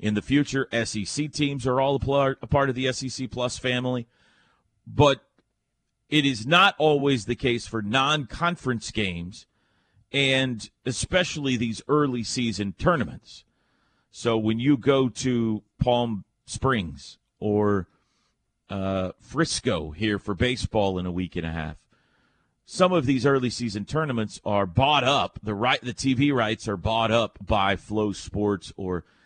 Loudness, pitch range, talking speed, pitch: -25 LUFS, 105-135 Hz, 145 wpm, 120 Hz